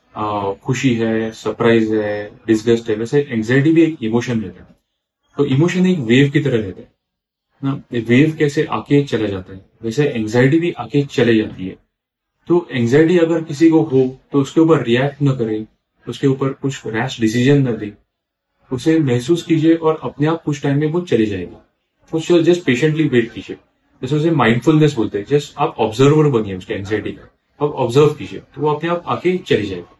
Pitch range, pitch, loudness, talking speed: 110-150 Hz, 135 Hz, -16 LUFS, 190 wpm